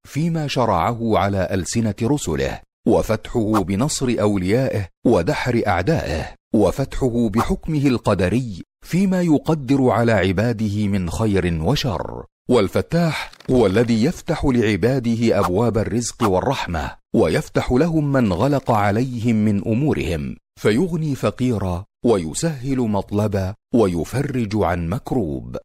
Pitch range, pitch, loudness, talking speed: 100-135 Hz, 115 Hz, -20 LUFS, 100 wpm